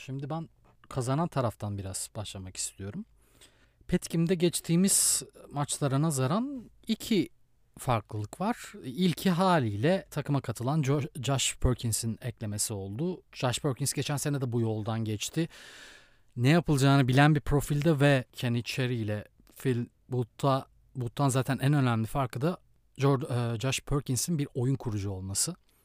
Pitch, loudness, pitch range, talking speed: 135 Hz, -29 LUFS, 115-150 Hz, 120 wpm